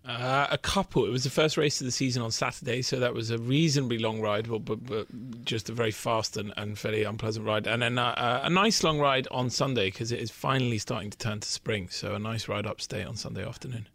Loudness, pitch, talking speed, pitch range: -29 LUFS, 120 Hz, 255 wpm, 110-135 Hz